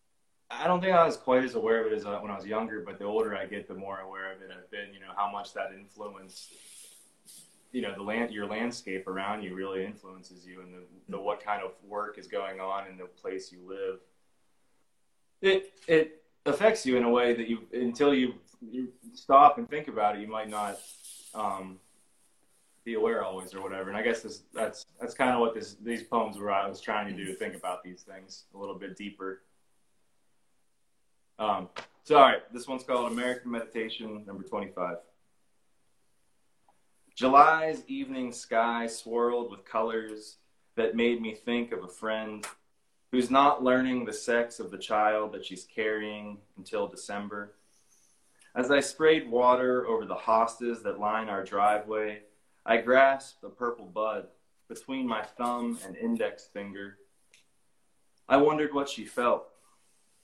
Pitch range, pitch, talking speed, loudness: 100-125 Hz, 110 Hz, 175 wpm, -29 LUFS